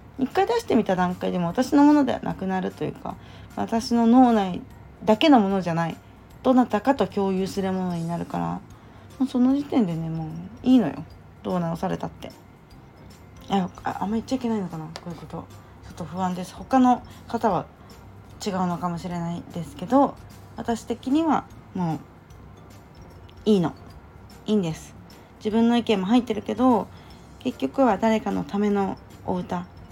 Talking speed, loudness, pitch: 320 characters per minute, -24 LUFS, 185 Hz